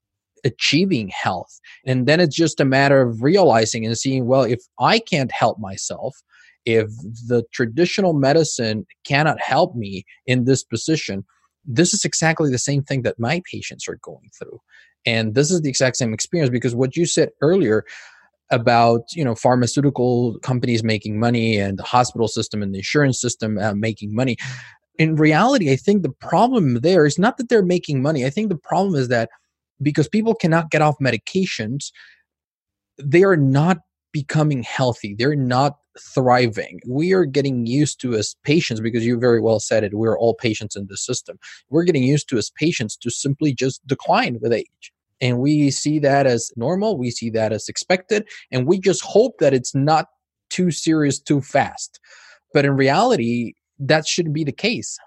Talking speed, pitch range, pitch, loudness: 180 wpm, 115-155 Hz, 130 Hz, -19 LUFS